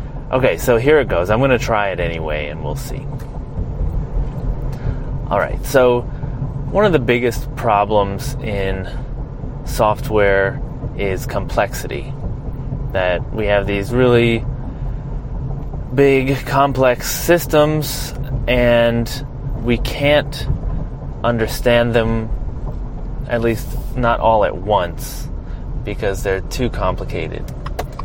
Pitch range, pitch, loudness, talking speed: 110-135 Hz, 125 Hz, -18 LUFS, 105 wpm